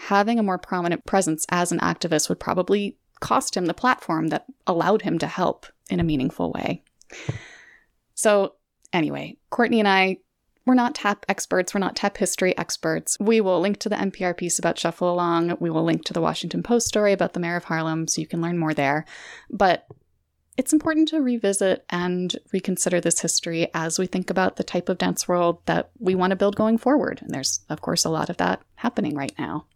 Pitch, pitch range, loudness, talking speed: 185 Hz, 170-205 Hz, -23 LUFS, 205 wpm